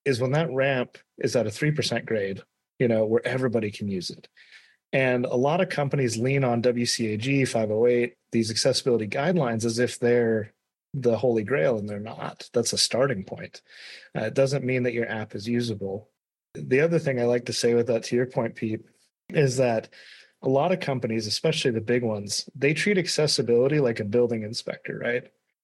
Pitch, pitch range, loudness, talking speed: 120 Hz, 115-135 Hz, -25 LUFS, 190 wpm